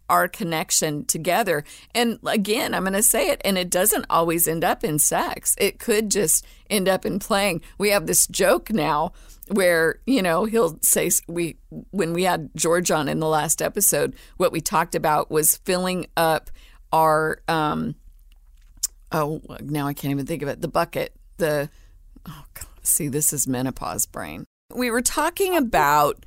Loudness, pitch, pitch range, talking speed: -21 LUFS, 165 Hz, 150-205 Hz, 175 wpm